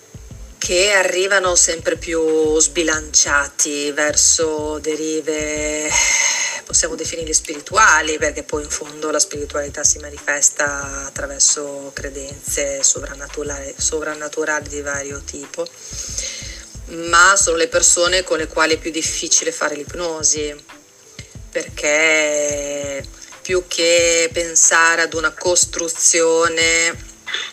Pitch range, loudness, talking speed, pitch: 145-170 Hz, -16 LUFS, 95 wpm, 155 Hz